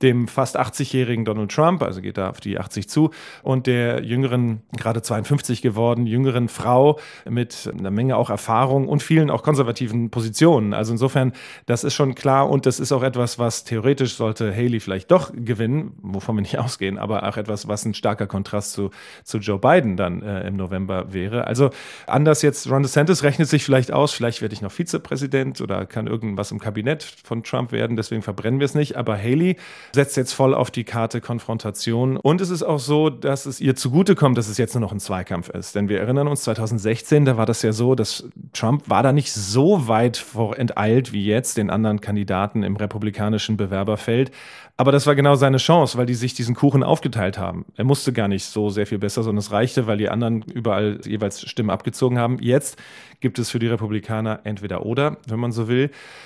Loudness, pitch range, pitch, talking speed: -21 LUFS, 105-135 Hz, 120 Hz, 205 wpm